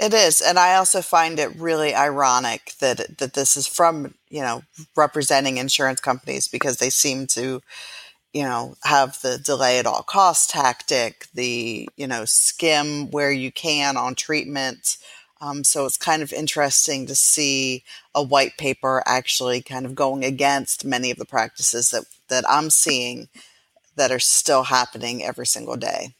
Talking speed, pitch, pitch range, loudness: 165 wpm, 135 Hz, 125-145 Hz, -19 LUFS